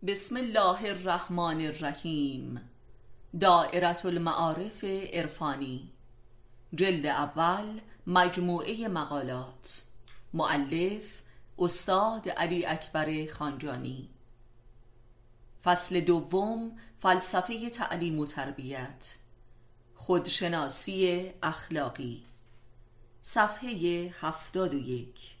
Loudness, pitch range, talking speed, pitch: -30 LUFS, 120-180 Hz, 65 wpm, 160 Hz